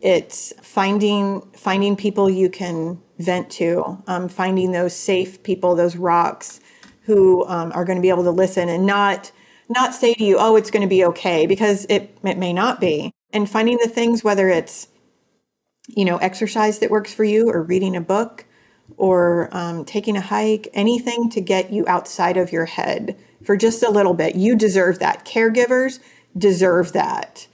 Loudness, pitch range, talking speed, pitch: -18 LUFS, 180-215 Hz, 180 wpm, 195 Hz